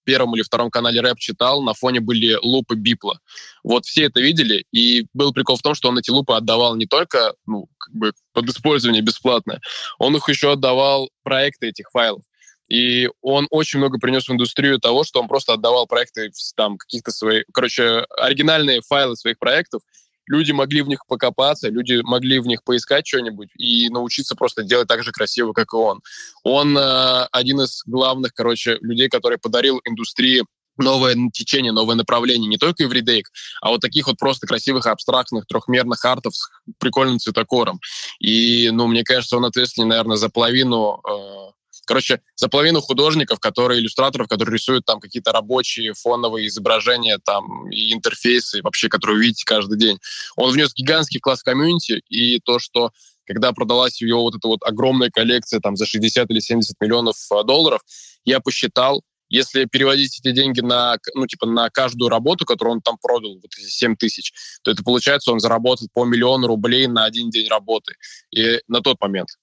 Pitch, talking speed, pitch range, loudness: 120 Hz, 180 wpm, 115-130 Hz, -17 LUFS